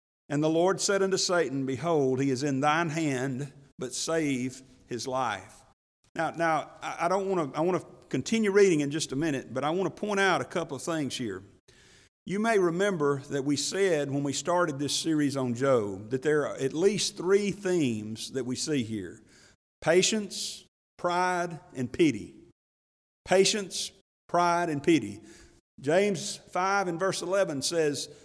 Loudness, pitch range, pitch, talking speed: -28 LUFS, 130-185 Hz, 150 Hz, 160 wpm